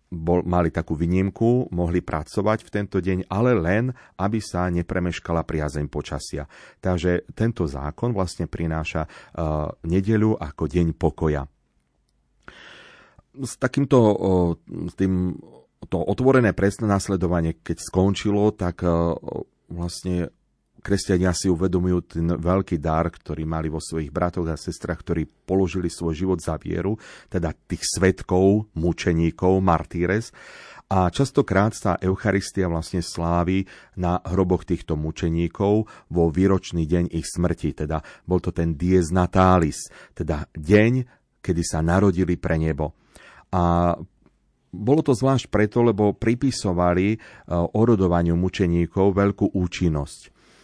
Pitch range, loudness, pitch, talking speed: 85-100 Hz, -23 LUFS, 90 Hz, 120 wpm